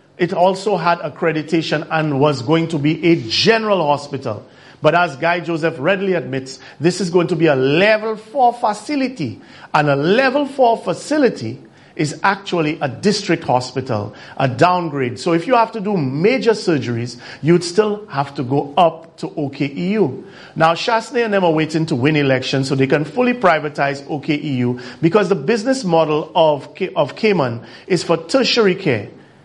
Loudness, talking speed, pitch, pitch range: -17 LUFS, 165 wpm, 165 Hz, 145-200 Hz